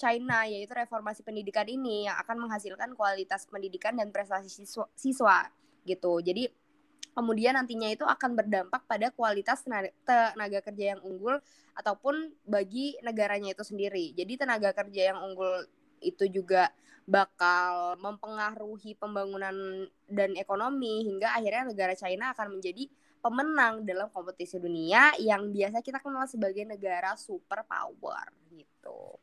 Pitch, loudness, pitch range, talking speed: 210 Hz, -30 LUFS, 195-245 Hz, 130 wpm